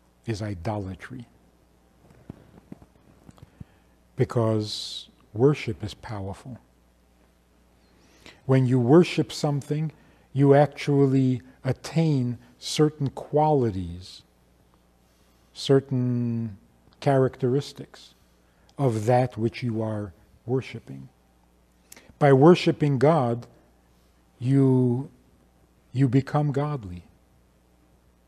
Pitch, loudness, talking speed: 115 Hz, -24 LUFS, 65 wpm